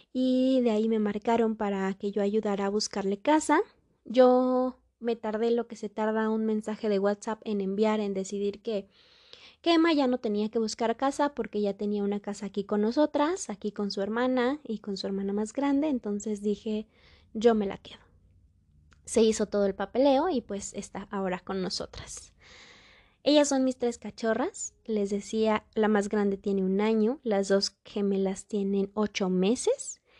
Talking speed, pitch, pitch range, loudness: 180 wpm, 215 Hz, 200-240 Hz, -28 LUFS